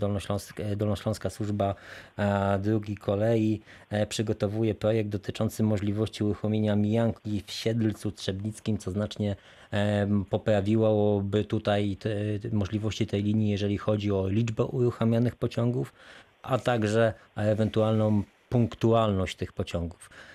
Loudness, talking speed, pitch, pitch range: -28 LUFS, 105 wpm, 105 Hz, 100-110 Hz